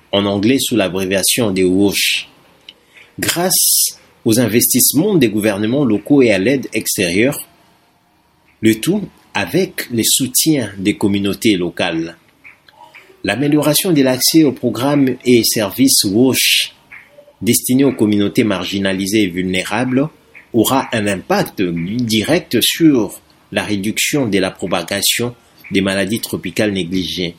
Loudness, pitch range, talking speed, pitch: -14 LUFS, 95-130 Hz, 115 wpm, 110 Hz